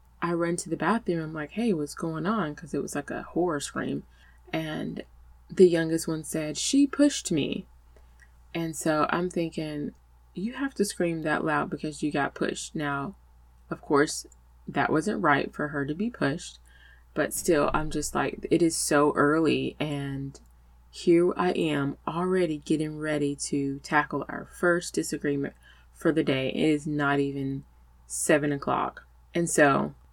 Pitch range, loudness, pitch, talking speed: 105-165 Hz, -27 LUFS, 150 Hz, 165 wpm